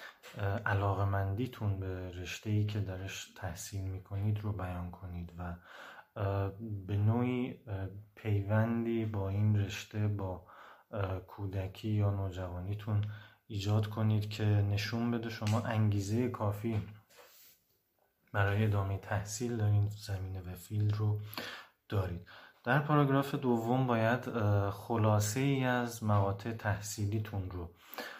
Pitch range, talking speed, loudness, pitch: 100-110 Hz, 110 wpm, -35 LUFS, 105 Hz